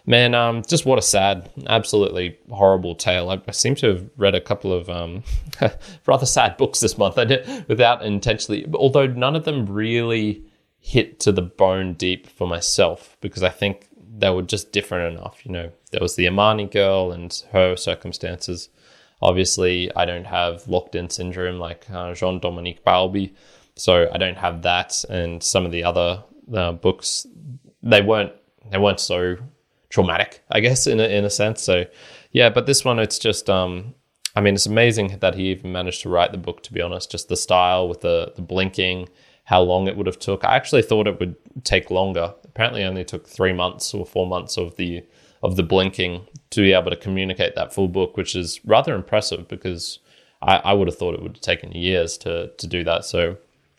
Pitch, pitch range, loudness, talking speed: 95 Hz, 90-105 Hz, -20 LUFS, 200 wpm